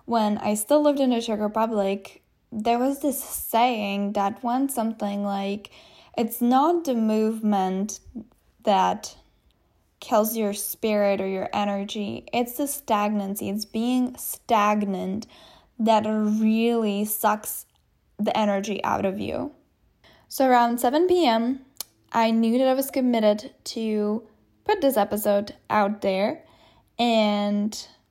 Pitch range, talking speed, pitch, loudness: 205-245 Hz, 125 wpm, 220 Hz, -24 LUFS